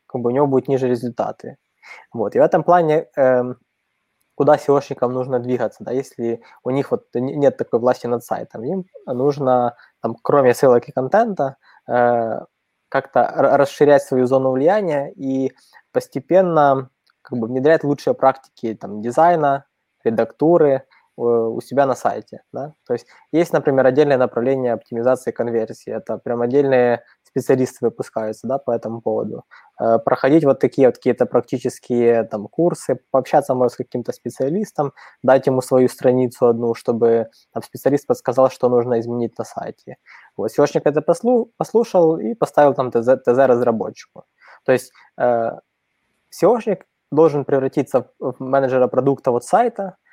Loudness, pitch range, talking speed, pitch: -18 LUFS, 120-145 Hz, 140 wpm, 130 Hz